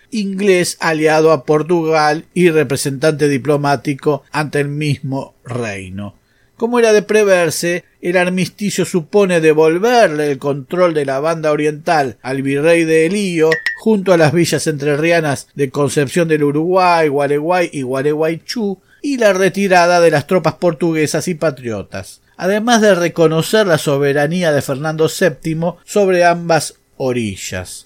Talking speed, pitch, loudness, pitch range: 130 wpm, 160 Hz, -14 LUFS, 145-180 Hz